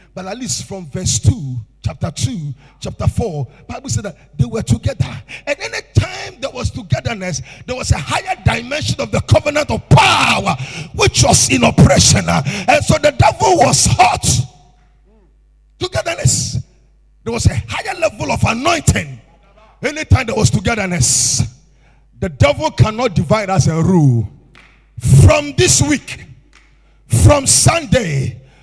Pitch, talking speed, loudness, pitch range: 140 Hz, 140 wpm, -14 LUFS, 125-195 Hz